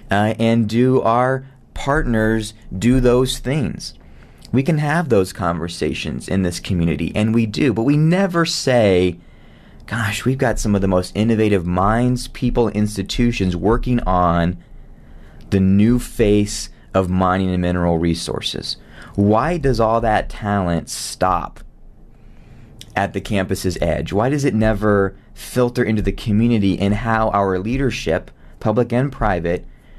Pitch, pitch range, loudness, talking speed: 105 Hz, 95-120 Hz, -18 LUFS, 140 wpm